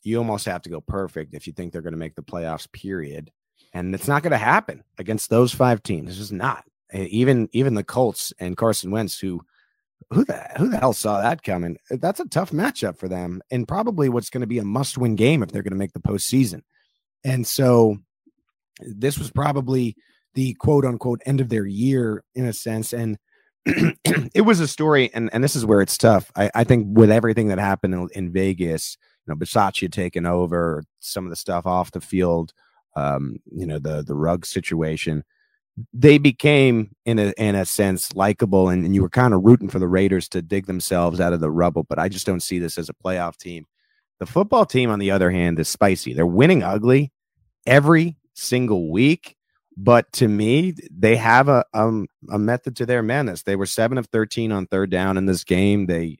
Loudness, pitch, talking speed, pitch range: -20 LUFS, 105 Hz, 205 wpm, 90-125 Hz